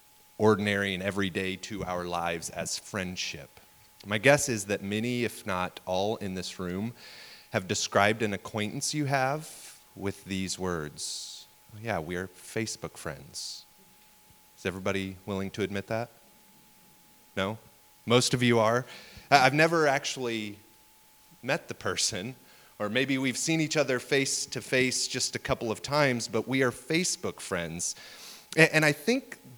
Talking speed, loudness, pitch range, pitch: 145 wpm, -29 LUFS, 95-130 Hz, 110 Hz